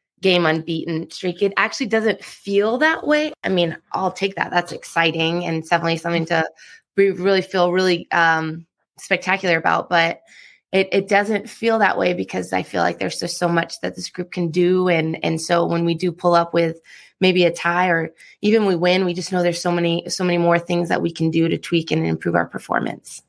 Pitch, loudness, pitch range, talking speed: 175 Hz, -19 LUFS, 165-185 Hz, 215 wpm